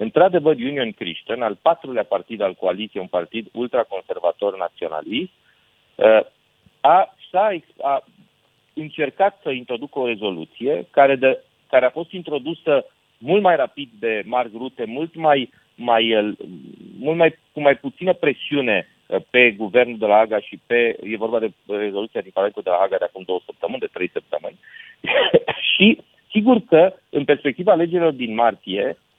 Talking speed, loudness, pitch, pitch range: 145 wpm, -20 LUFS, 145 Hz, 115-195 Hz